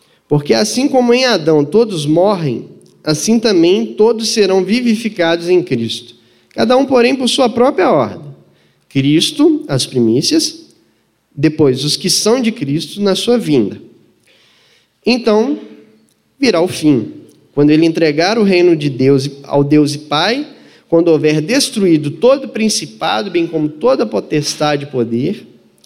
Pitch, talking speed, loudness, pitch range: 175 Hz, 140 wpm, -13 LUFS, 150-235 Hz